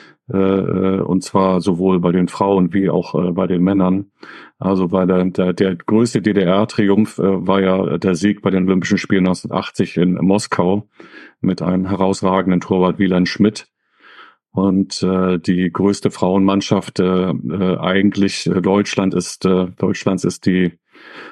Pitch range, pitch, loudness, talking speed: 90-100 Hz, 95 Hz, -17 LUFS, 125 wpm